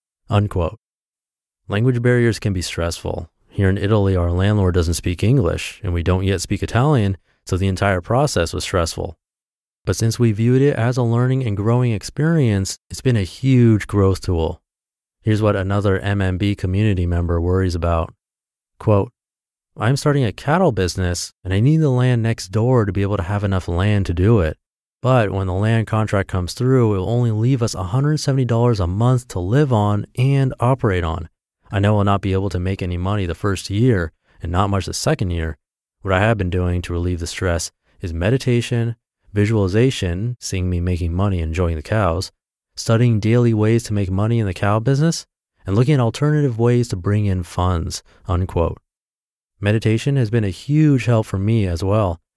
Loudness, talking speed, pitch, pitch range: -19 LUFS, 185 wpm, 100 Hz, 90-115 Hz